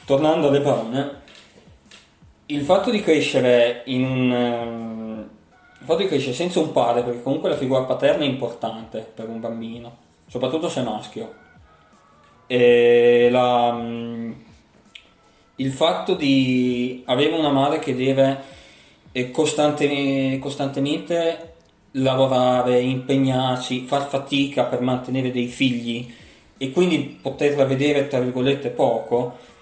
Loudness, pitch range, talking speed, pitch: -21 LUFS, 120-140 Hz, 115 wpm, 130 Hz